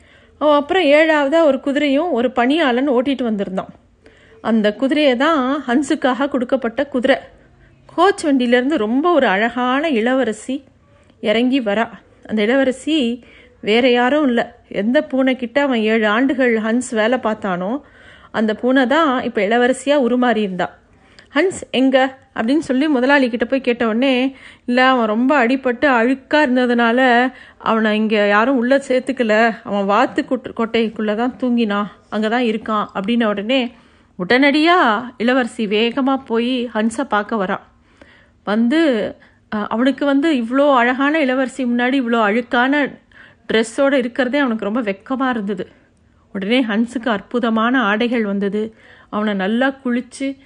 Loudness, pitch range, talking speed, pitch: -17 LUFS, 225-275 Hz, 120 wpm, 250 Hz